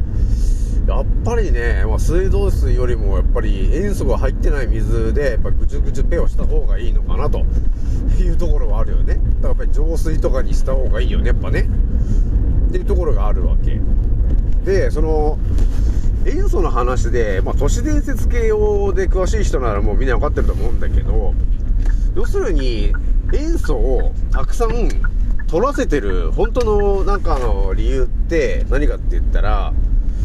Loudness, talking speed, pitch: -19 LUFS, 335 characters per minute, 195 Hz